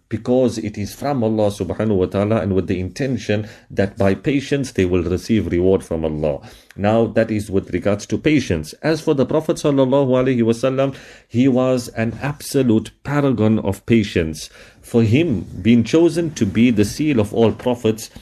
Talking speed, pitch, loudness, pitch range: 175 wpm, 115 Hz, -18 LUFS, 100-130 Hz